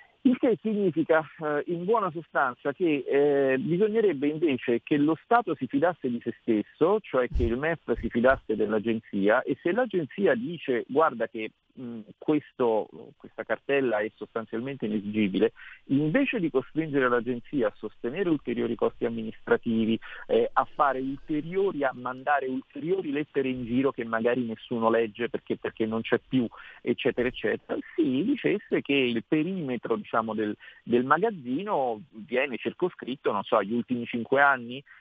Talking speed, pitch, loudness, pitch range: 145 wpm, 130 Hz, -27 LUFS, 115-160 Hz